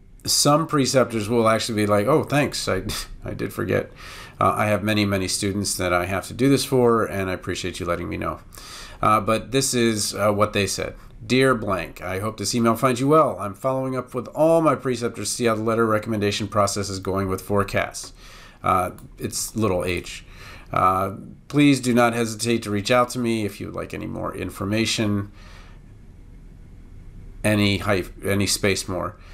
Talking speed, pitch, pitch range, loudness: 190 wpm, 105 Hz, 95-120 Hz, -22 LUFS